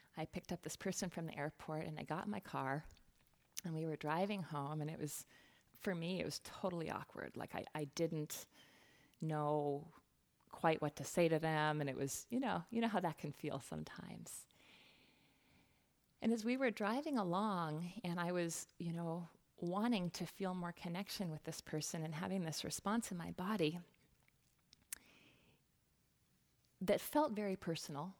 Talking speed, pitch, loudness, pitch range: 170 wpm, 170 Hz, -42 LUFS, 155-190 Hz